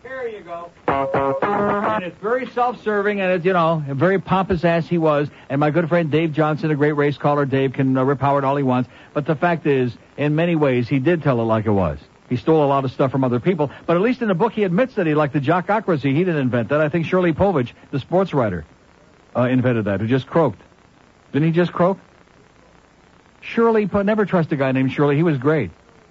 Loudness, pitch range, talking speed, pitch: -19 LUFS, 135-180 Hz, 235 wpm, 155 Hz